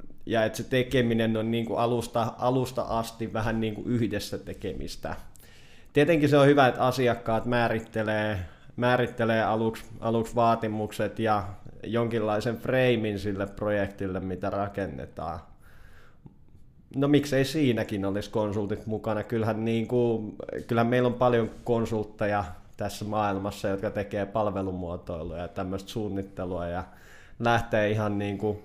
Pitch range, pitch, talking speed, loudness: 100-115 Hz, 110 Hz, 125 wpm, -28 LUFS